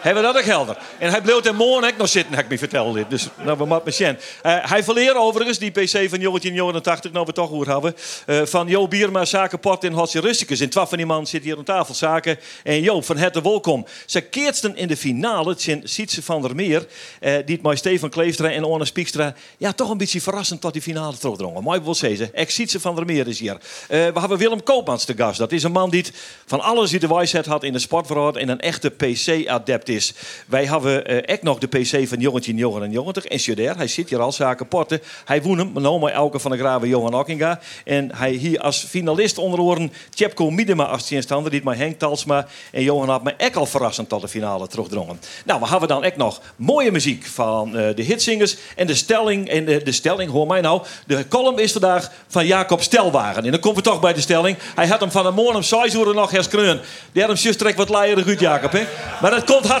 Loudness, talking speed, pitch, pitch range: -19 LUFS, 245 wpm, 165 Hz, 140-195 Hz